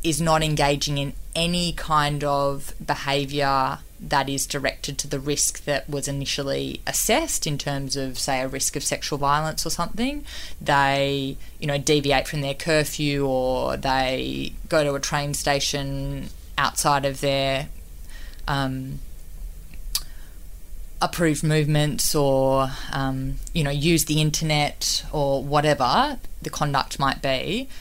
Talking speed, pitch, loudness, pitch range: 135 wpm, 140 Hz, -23 LUFS, 135-150 Hz